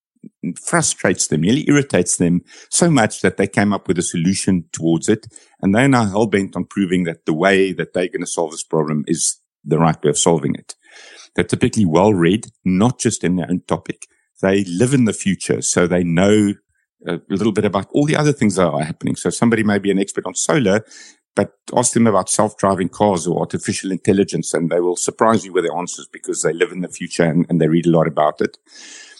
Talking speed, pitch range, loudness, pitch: 220 wpm, 85-115 Hz, -17 LUFS, 100 Hz